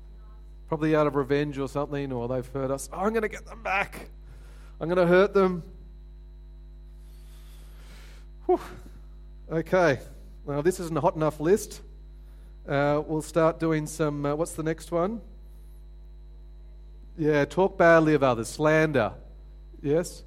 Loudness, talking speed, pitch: -26 LUFS, 145 wpm, 145 Hz